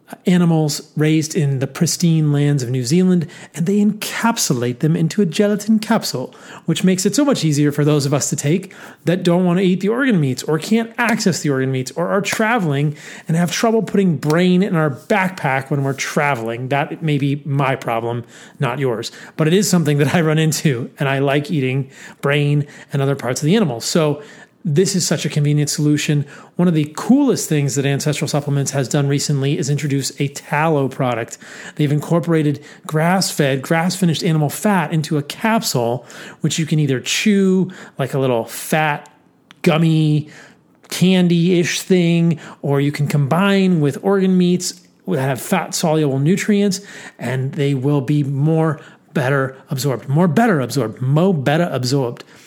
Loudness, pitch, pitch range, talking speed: -17 LUFS, 155 Hz, 140-185 Hz, 175 wpm